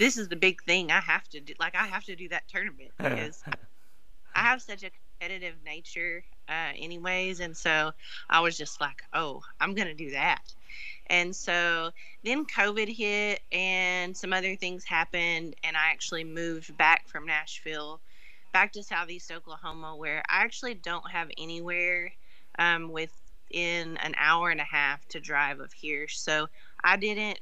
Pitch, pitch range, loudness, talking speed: 170 Hz, 160-185 Hz, -28 LUFS, 170 wpm